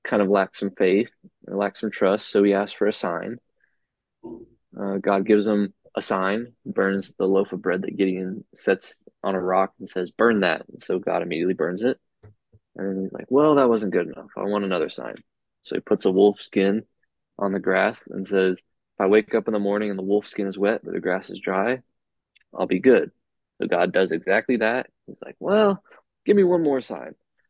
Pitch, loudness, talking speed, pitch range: 100 Hz, -23 LUFS, 215 wpm, 95-105 Hz